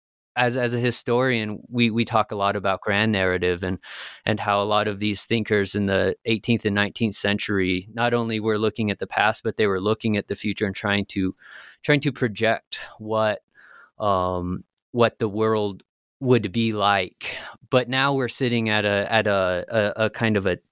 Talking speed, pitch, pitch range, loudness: 195 wpm, 110 Hz, 100-115 Hz, -23 LUFS